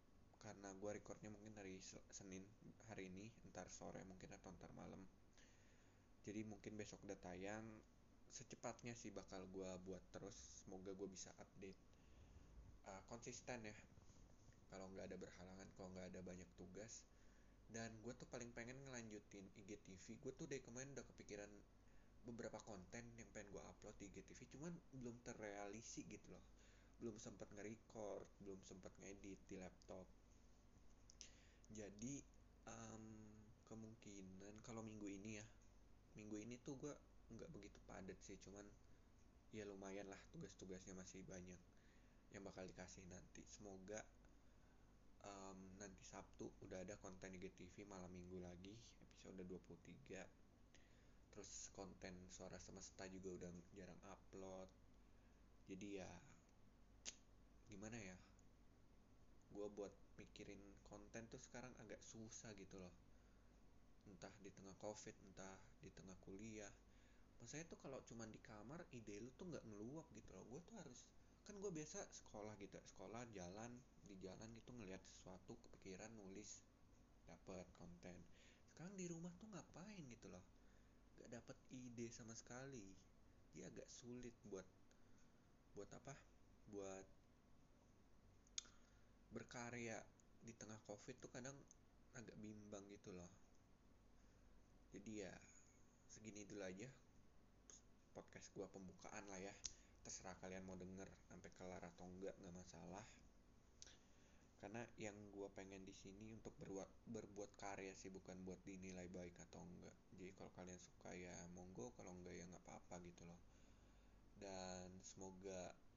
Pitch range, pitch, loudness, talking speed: 95-110 Hz, 100 Hz, -59 LUFS, 135 wpm